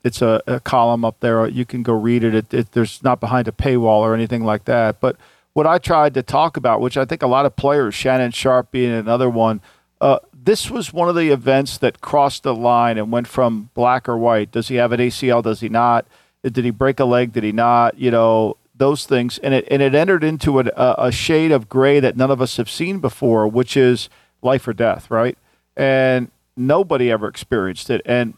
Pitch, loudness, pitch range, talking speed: 125 Hz, -17 LUFS, 115-135 Hz, 230 wpm